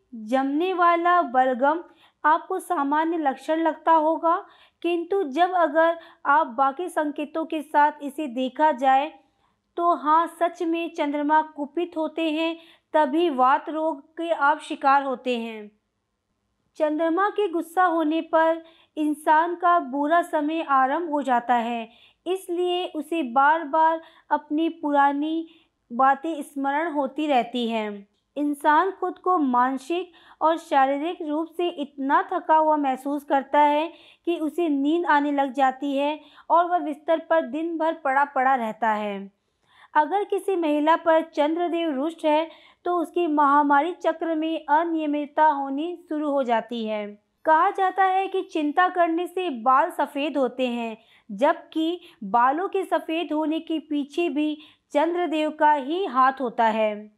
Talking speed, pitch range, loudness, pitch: 140 wpm, 280-335 Hz, -23 LUFS, 310 Hz